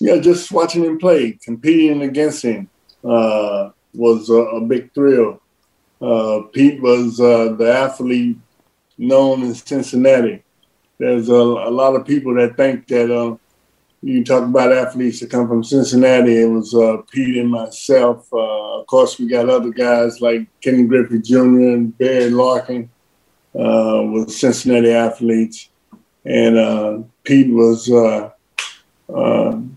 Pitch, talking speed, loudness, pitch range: 120 Hz, 145 wpm, -15 LUFS, 115-130 Hz